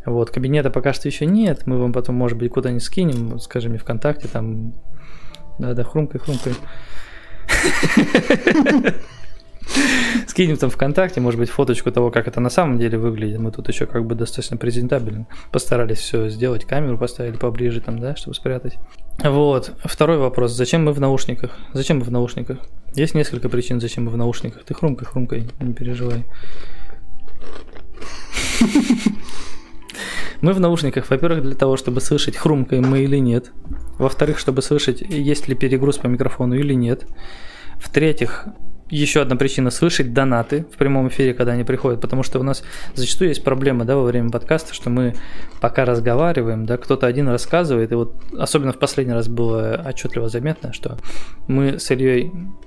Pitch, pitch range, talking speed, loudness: 130 Hz, 120-145 Hz, 160 wpm, -19 LUFS